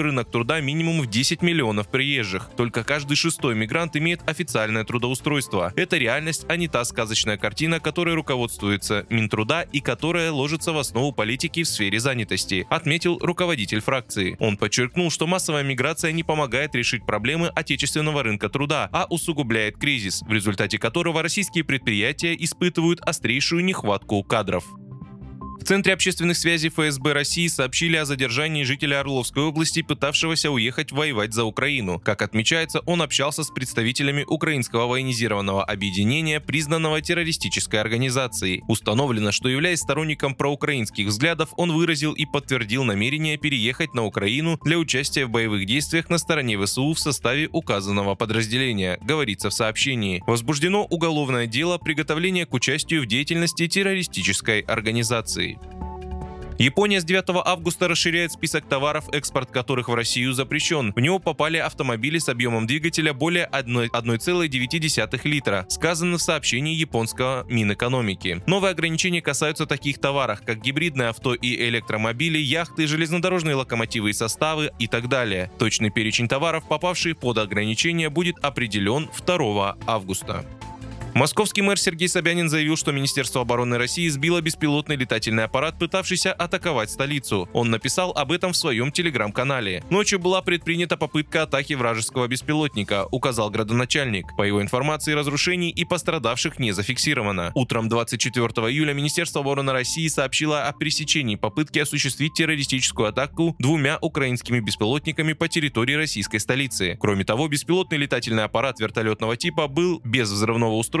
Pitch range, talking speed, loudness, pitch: 115-160 Hz, 140 wpm, -22 LUFS, 140 Hz